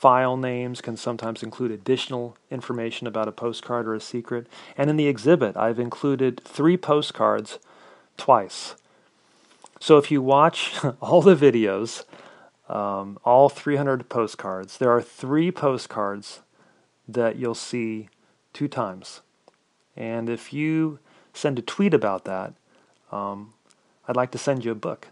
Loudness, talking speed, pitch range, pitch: -23 LUFS, 140 wpm, 115-140 Hz, 120 Hz